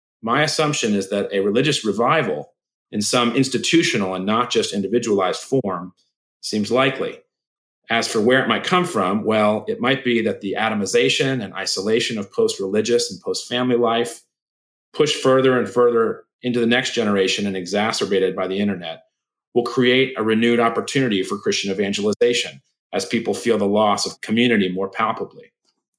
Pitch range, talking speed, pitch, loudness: 100-130 Hz, 160 wpm, 120 Hz, -20 LUFS